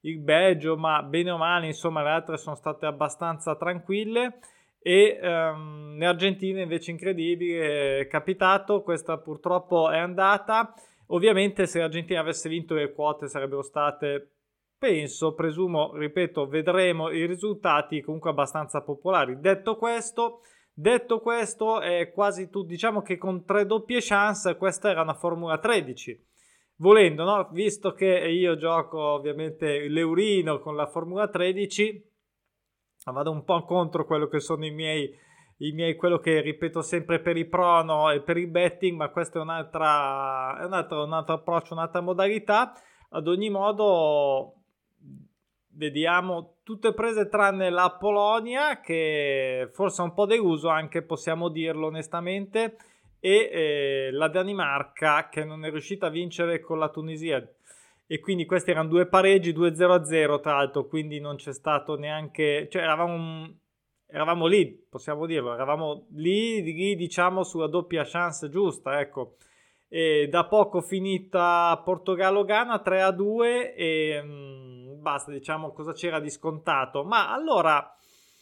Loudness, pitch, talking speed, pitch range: -25 LUFS, 170 Hz, 140 wpm, 155-190 Hz